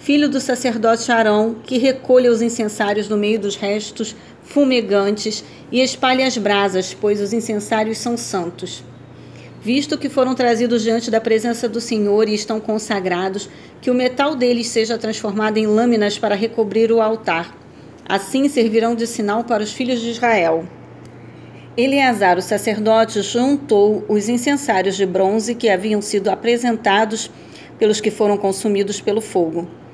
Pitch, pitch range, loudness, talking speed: 225 Hz, 205-240 Hz, -18 LUFS, 145 wpm